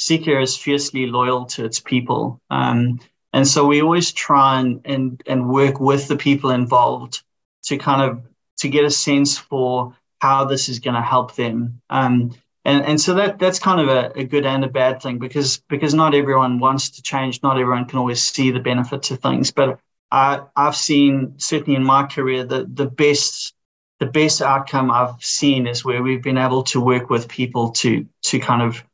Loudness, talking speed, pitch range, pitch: -18 LUFS, 200 wpm, 125-140 Hz, 135 Hz